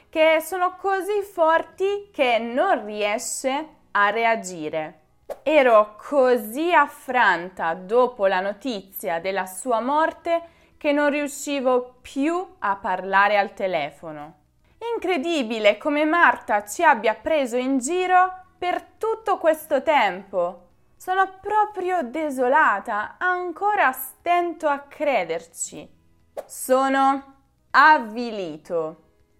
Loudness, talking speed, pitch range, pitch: -22 LUFS, 95 wpm, 205-335 Hz, 275 Hz